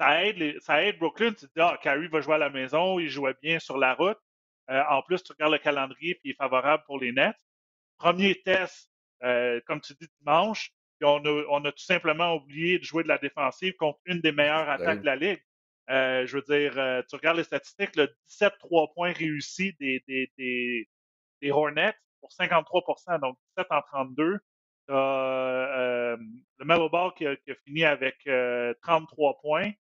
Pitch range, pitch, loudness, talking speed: 130-165 Hz, 150 Hz, -27 LUFS, 200 wpm